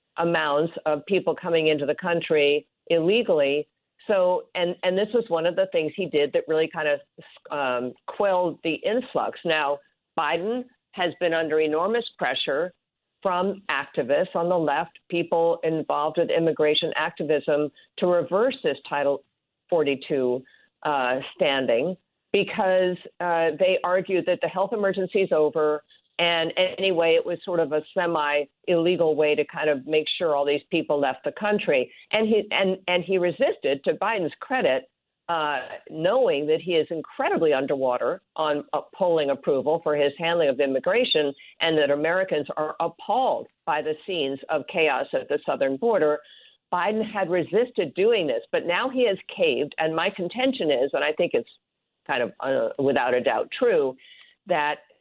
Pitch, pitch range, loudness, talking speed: 170 Hz, 150-195 Hz, -24 LUFS, 160 wpm